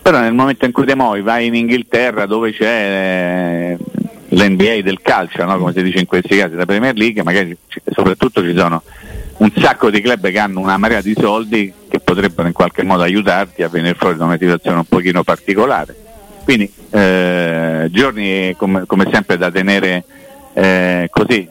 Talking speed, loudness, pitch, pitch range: 180 wpm, -14 LUFS, 95 Hz, 90-110 Hz